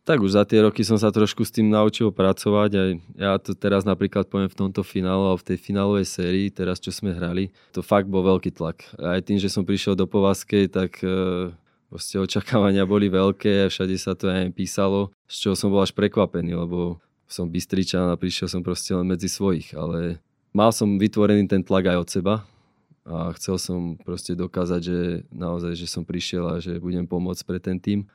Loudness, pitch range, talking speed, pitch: -23 LUFS, 90-100 Hz, 205 wpm, 95 Hz